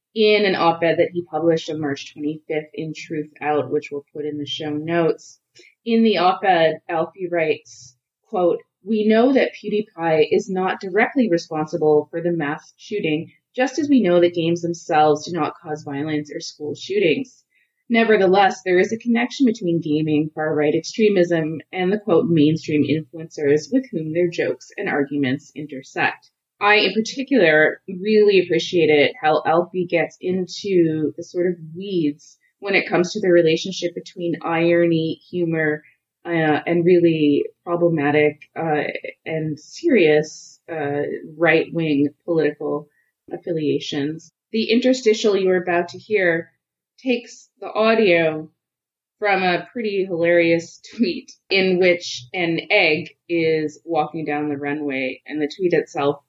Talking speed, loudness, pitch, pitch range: 140 wpm, -20 LUFS, 165 Hz, 150-190 Hz